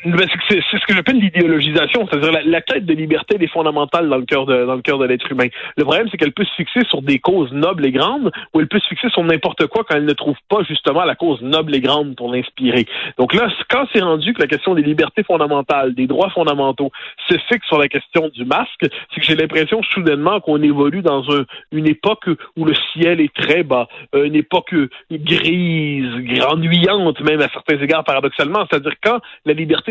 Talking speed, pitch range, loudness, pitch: 220 wpm, 145-180 Hz, -16 LUFS, 160 Hz